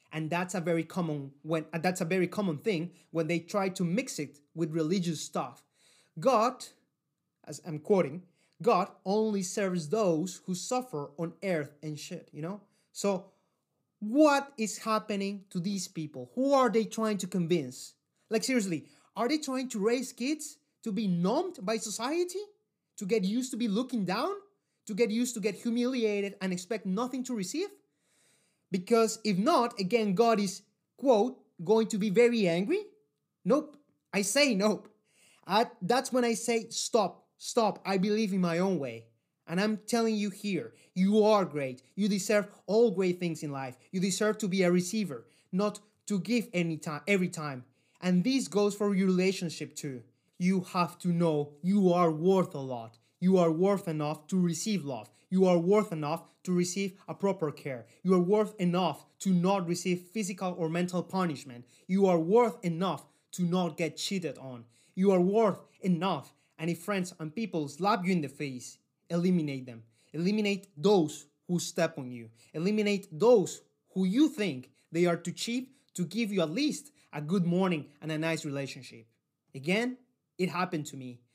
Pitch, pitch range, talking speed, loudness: 185 Hz, 160-215 Hz, 175 wpm, -30 LUFS